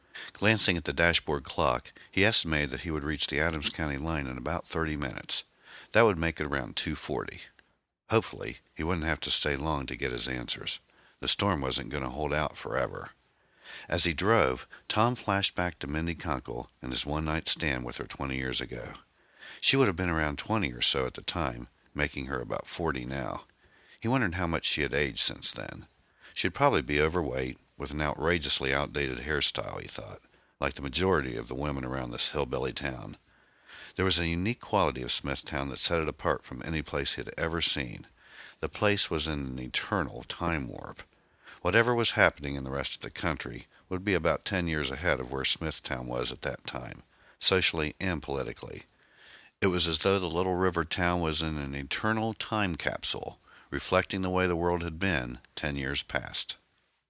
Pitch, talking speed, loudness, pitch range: 75 Hz, 195 wpm, -28 LUFS, 70-90 Hz